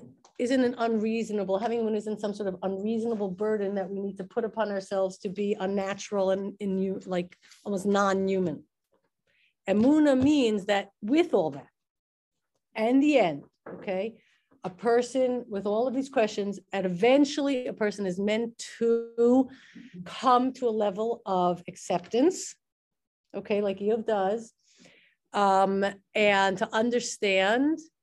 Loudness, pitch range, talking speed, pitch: -27 LUFS, 195-235 Hz, 140 wpm, 210 Hz